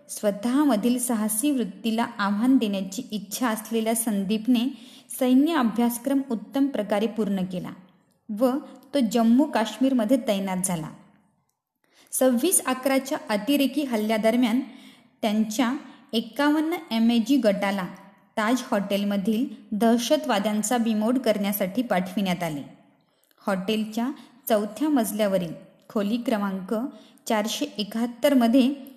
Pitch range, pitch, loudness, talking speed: 210-260 Hz, 230 Hz, -24 LUFS, 90 wpm